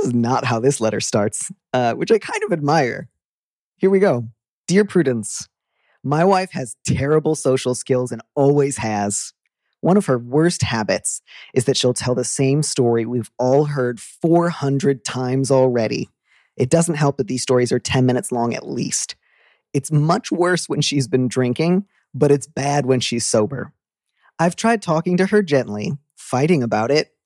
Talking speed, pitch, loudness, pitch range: 170 wpm, 135 Hz, -19 LUFS, 125-165 Hz